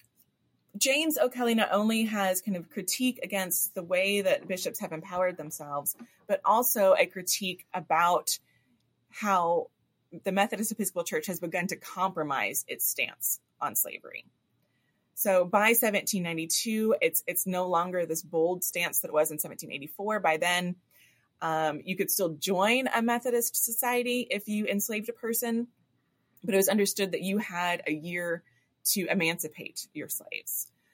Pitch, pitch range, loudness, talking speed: 190 Hz, 170-220 Hz, -28 LUFS, 150 wpm